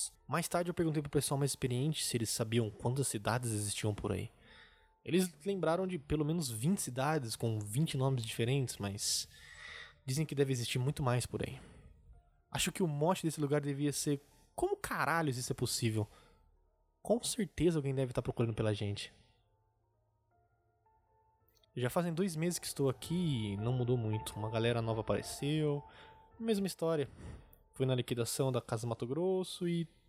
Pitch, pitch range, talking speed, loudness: 130 Hz, 110-155 Hz, 165 wpm, -36 LUFS